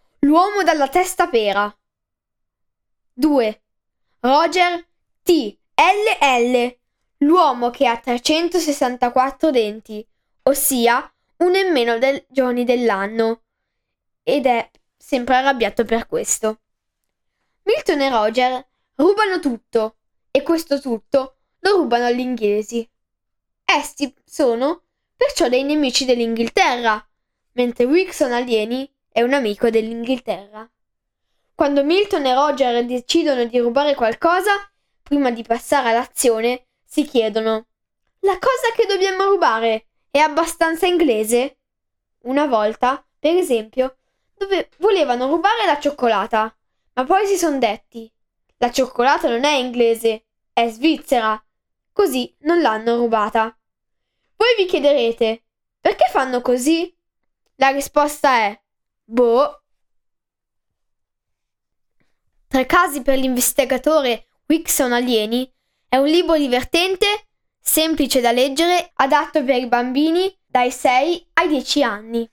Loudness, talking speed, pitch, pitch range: -18 LUFS, 110 wpm, 265 Hz, 235-320 Hz